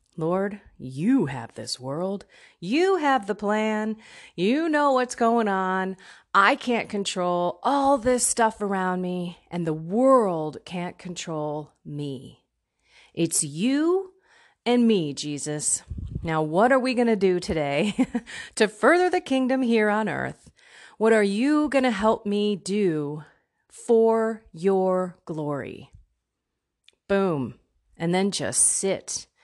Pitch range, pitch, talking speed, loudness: 165-240 Hz, 200 Hz, 130 wpm, -24 LUFS